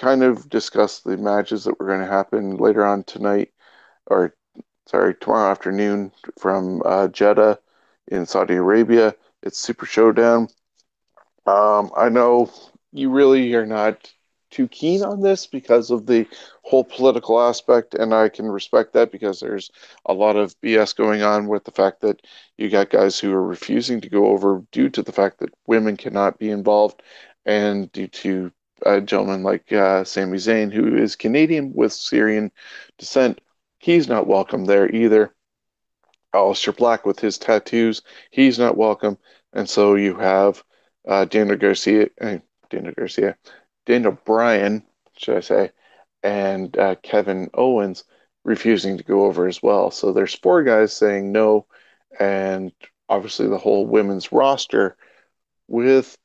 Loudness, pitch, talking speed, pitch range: -19 LUFS, 105 Hz, 155 wpm, 100-115 Hz